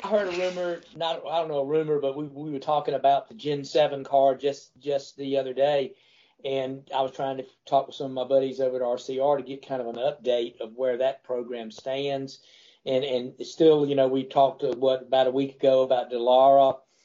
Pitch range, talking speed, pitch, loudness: 130-145 Hz, 220 wpm, 135 Hz, -25 LUFS